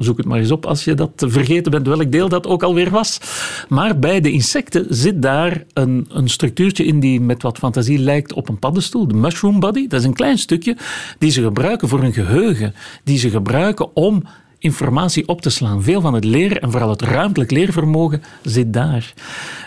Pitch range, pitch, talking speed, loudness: 125-175 Hz, 145 Hz, 205 wpm, -16 LUFS